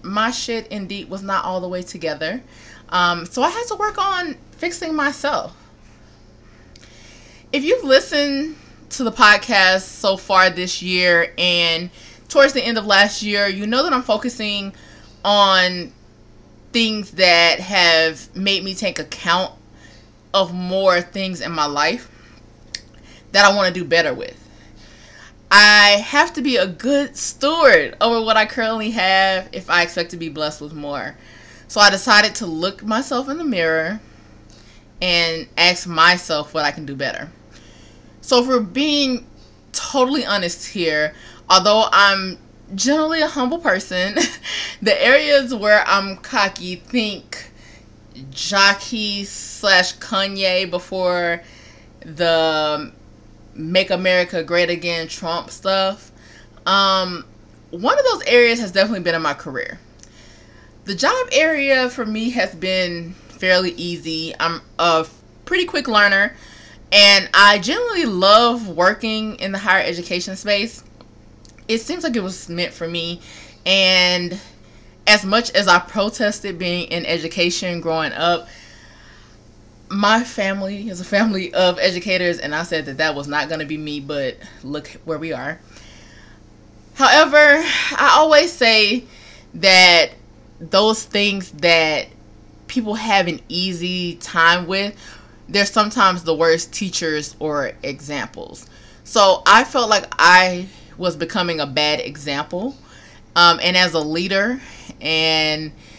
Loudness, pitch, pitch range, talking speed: -16 LUFS, 185 Hz, 160-210 Hz, 135 wpm